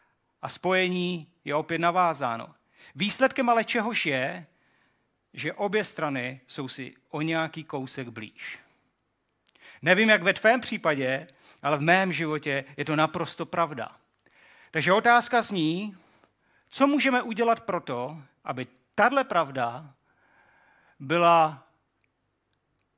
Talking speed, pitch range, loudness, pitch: 110 wpm, 140-195 Hz, -26 LUFS, 165 Hz